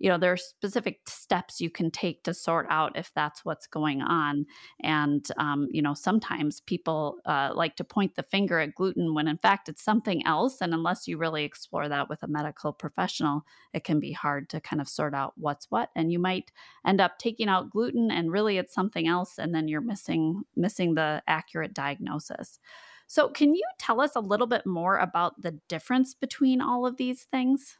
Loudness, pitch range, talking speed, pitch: -28 LUFS, 155-210 Hz, 205 wpm, 175 Hz